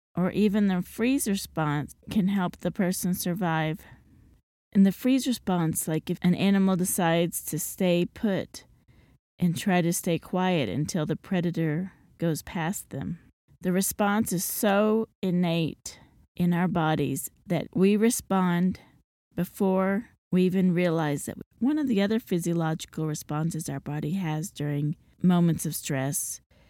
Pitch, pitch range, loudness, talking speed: 180 Hz, 160-195 Hz, -27 LUFS, 140 wpm